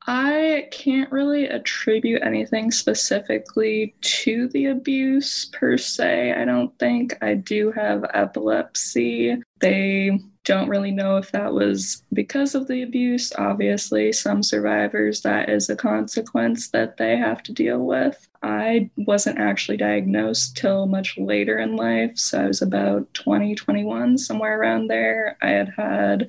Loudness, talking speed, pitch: -21 LUFS, 145 wpm, 130 Hz